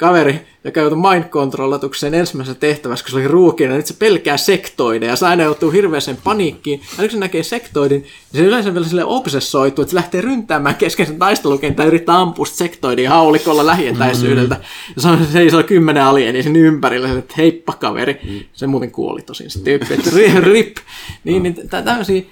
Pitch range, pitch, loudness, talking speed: 135-175 Hz, 155 Hz, -14 LUFS, 190 wpm